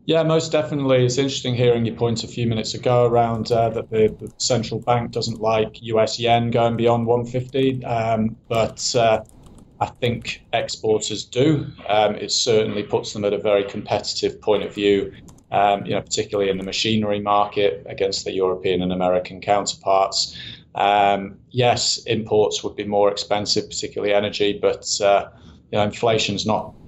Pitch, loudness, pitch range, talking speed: 110 Hz, -21 LUFS, 100-120 Hz, 175 wpm